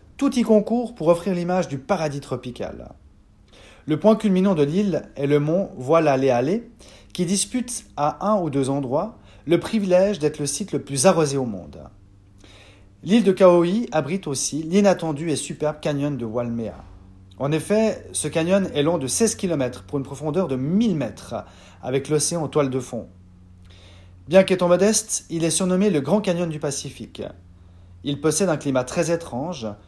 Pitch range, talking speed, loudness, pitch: 125-185 Hz, 170 wpm, -21 LUFS, 150 Hz